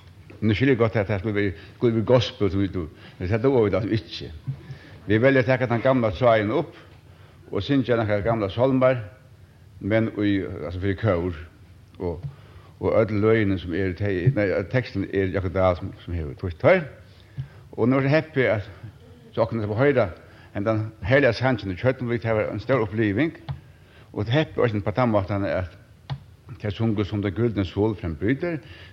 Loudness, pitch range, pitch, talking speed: -23 LUFS, 95-125 Hz, 105 Hz, 190 wpm